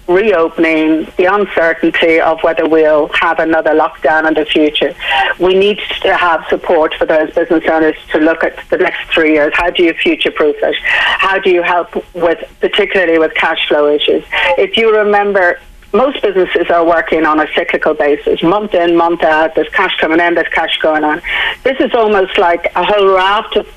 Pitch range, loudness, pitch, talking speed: 160-190 Hz, -11 LUFS, 170 Hz, 190 wpm